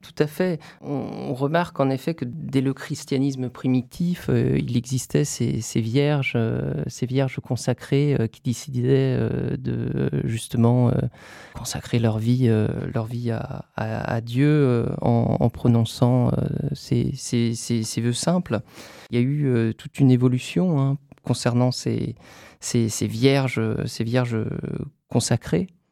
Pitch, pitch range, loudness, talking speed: 125 Hz, 120-140 Hz, -23 LUFS, 125 wpm